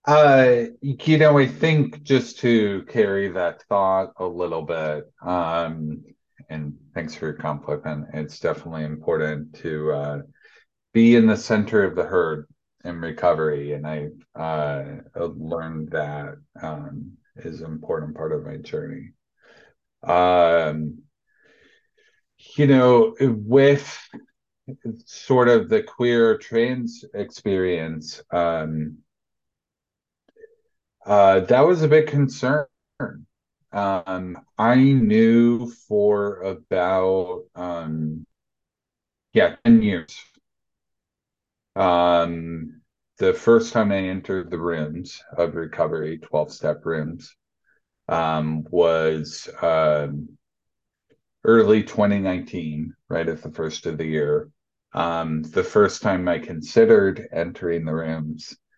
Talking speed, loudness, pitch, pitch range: 110 wpm, -21 LUFS, 95 Hz, 80-120 Hz